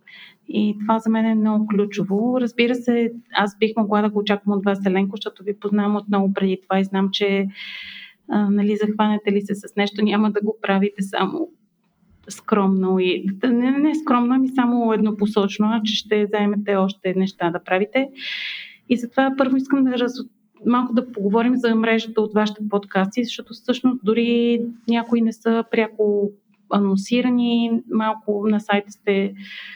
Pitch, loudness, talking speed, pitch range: 215 Hz, -20 LUFS, 165 wpm, 200-235 Hz